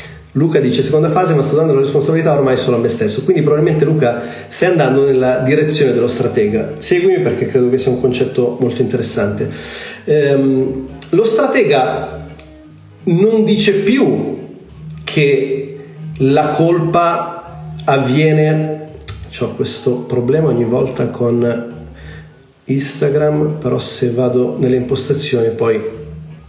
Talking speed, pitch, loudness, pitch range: 125 wpm, 135 Hz, -14 LUFS, 125-155 Hz